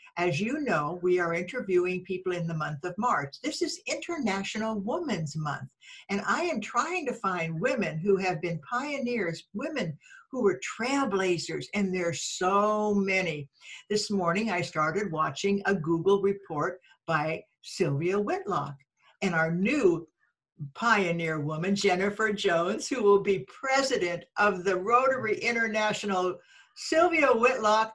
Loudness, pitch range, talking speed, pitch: -28 LUFS, 175-235 Hz, 135 wpm, 195 Hz